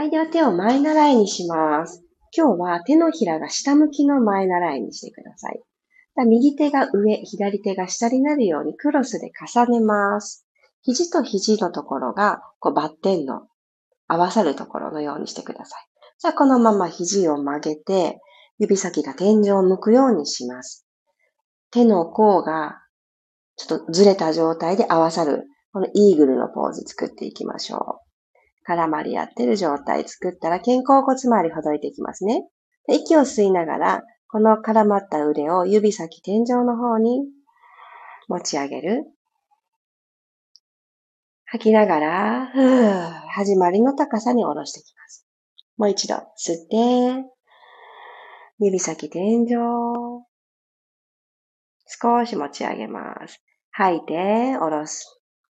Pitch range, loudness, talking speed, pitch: 175-260 Hz, -20 LUFS, 270 characters per minute, 215 Hz